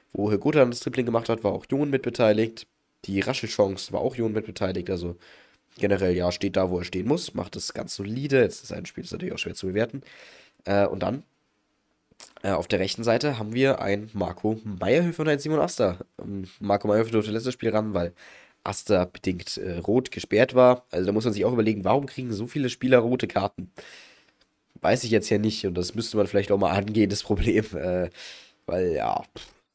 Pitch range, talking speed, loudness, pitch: 100-125 Hz, 195 wpm, -25 LUFS, 110 Hz